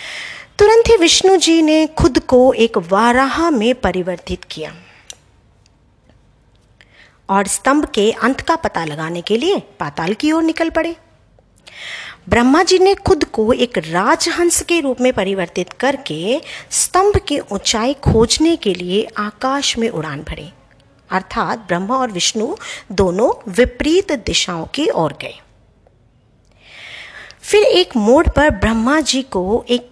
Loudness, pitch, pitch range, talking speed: -15 LUFS, 255 Hz, 200-325 Hz, 130 wpm